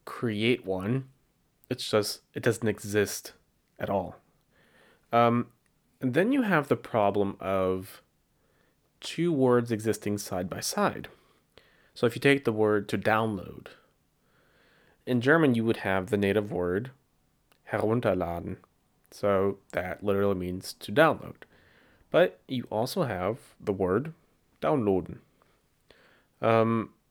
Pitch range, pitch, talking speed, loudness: 100-125 Hz, 110 Hz, 120 wpm, -28 LUFS